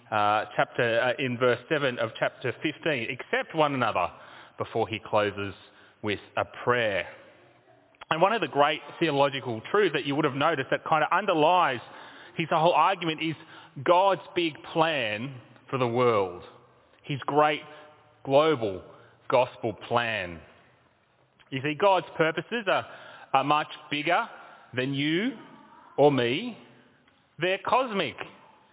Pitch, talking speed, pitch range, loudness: 145 Hz, 130 wpm, 120-165 Hz, -26 LUFS